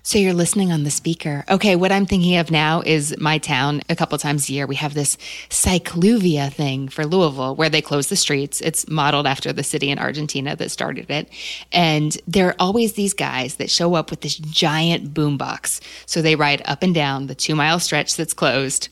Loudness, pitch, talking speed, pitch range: -19 LUFS, 155 Hz, 215 wpm, 145-170 Hz